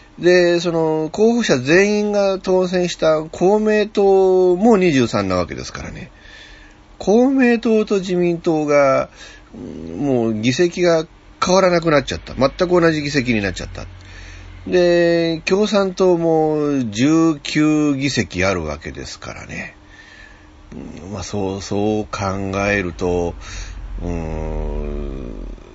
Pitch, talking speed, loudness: 150 Hz, 205 characters per minute, -17 LUFS